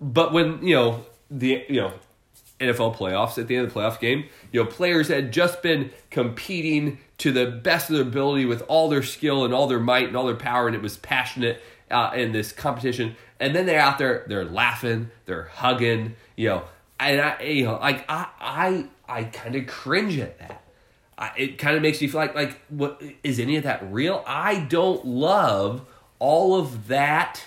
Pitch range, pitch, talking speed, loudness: 115-150 Hz, 125 Hz, 205 wpm, -23 LUFS